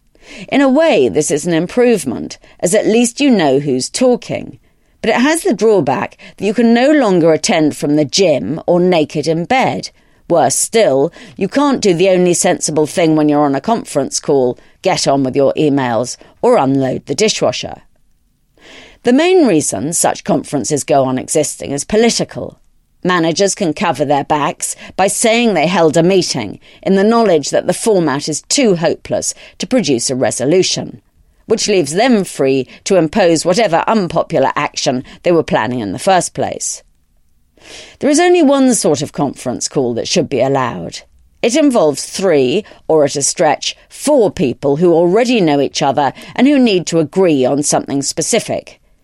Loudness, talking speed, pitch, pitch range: -13 LUFS, 170 wpm, 175 Hz, 145-225 Hz